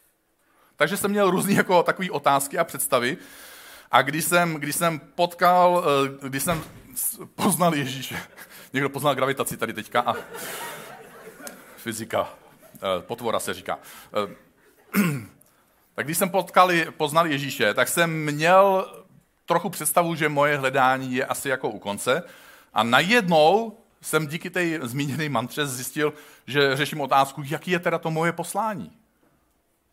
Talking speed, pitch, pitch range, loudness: 130 wpm, 155 Hz, 140-175 Hz, -23 LUFS